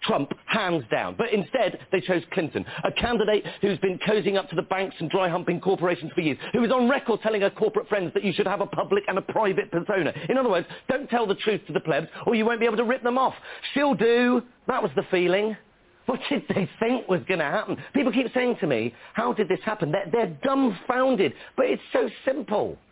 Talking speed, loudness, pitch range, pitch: 235 wpm, -25 LUFS, 185-235 Hz, 205 Hz